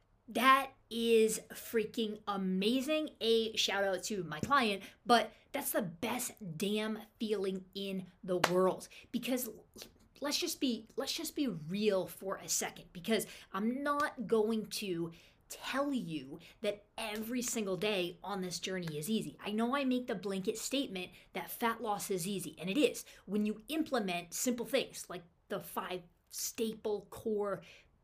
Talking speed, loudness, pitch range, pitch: 150 wpm, -35 LUFS, 190-235 Hz, 215 Hz